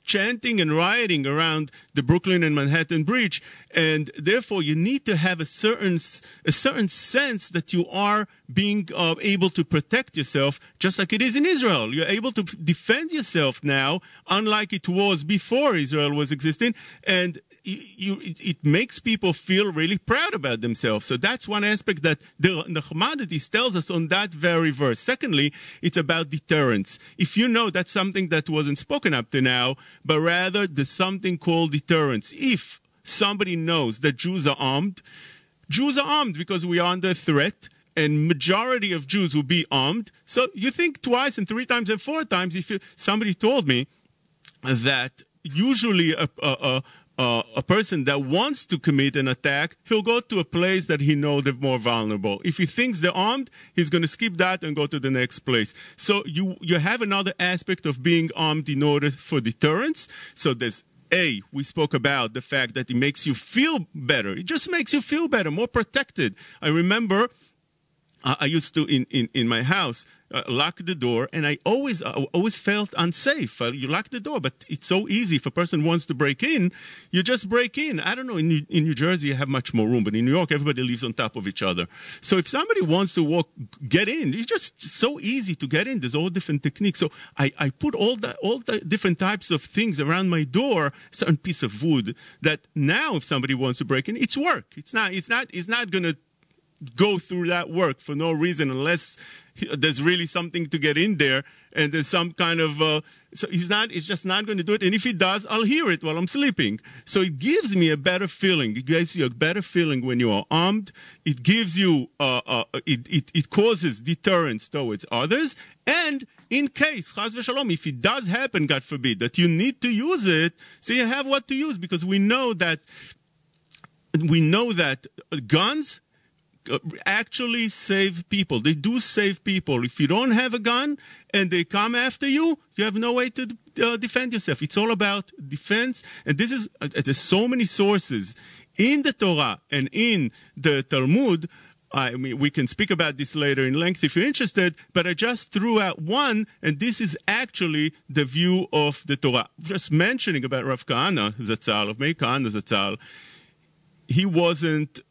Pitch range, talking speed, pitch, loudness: 150-205 Hz, 200 wpm, 170 Hz, -23 LUFS